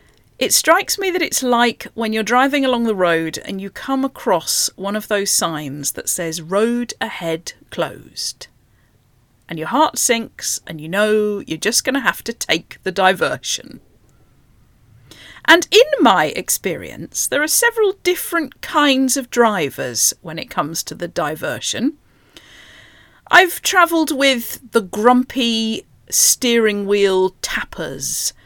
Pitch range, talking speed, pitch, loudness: 185-275 Hz, 140 wpm, 230 Hz, -17 LUFS